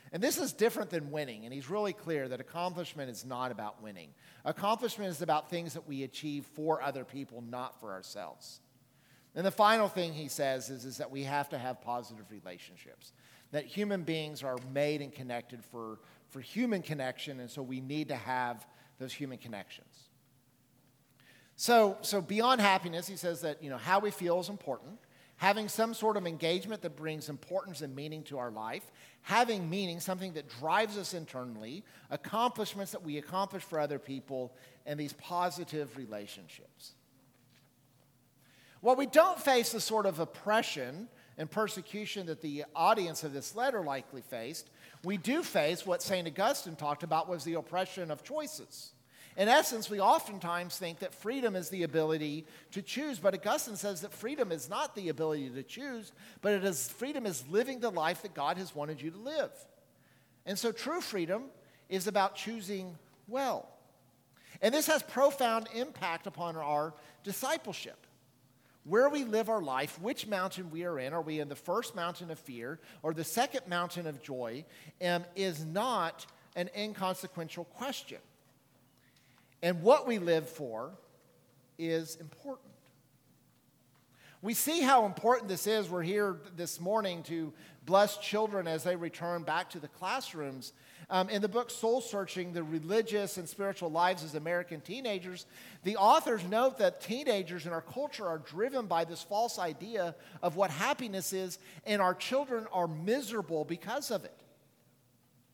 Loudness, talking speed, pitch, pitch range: -34 LUFS, 165 wpm, 170 Hz, 140-205 Hz